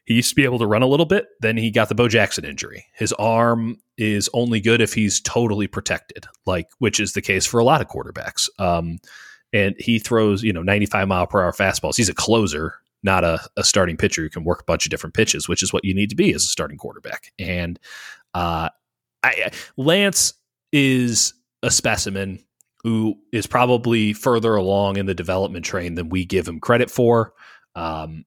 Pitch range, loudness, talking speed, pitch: 95-115 Hz, -20 LUFS, 205 wpm, 105 Hz